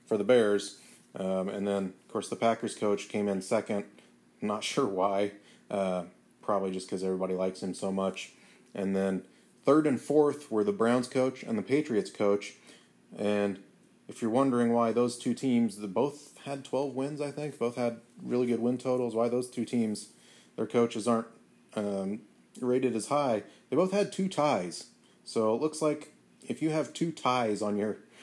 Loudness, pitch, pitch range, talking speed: -30 LUFS, 115 Hz, 100-130 Hz, 185 wpm